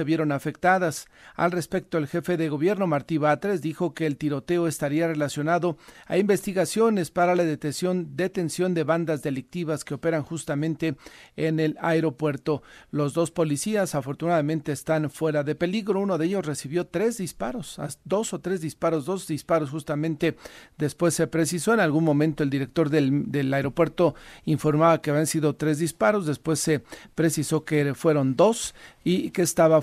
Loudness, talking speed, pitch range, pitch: -25 LUFS, 160 wpm, 150-175 Hz, 160 Hz